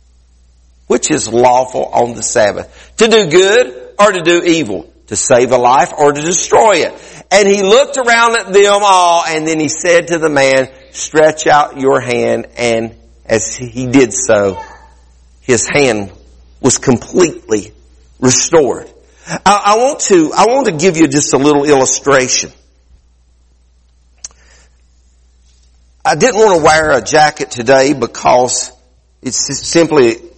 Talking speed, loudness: 145 wpm, -10 LUFS